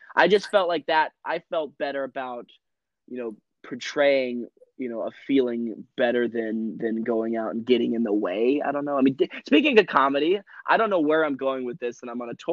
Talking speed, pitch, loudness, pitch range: 230 wpm, 125 Hz, -24 LUFS, 115-140 Hz